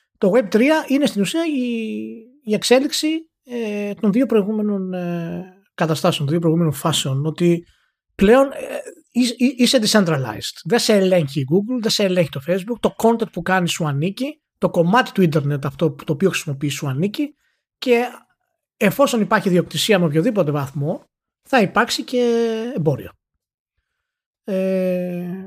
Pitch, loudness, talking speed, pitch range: 200 Hz, -19 LUFS, 155 wpm, 170-245 Hz